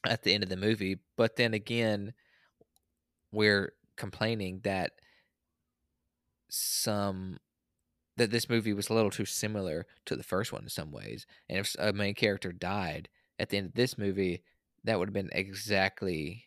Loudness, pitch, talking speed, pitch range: -32 LUFS, 100 Hz, 165 wpm, 90-105 Hz